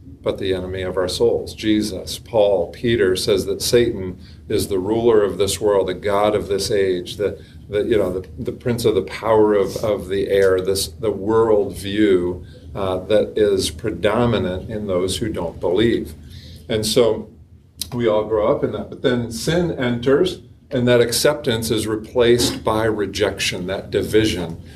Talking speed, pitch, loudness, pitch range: 170 wpm, 105 Hz, -19 LUFS, 95-120 Hz